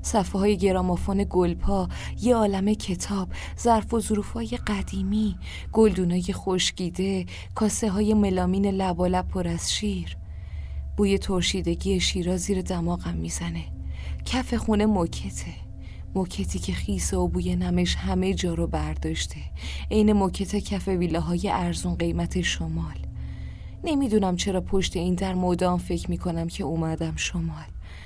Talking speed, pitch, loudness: 125 wpm, 175 Hz, -26 LUFS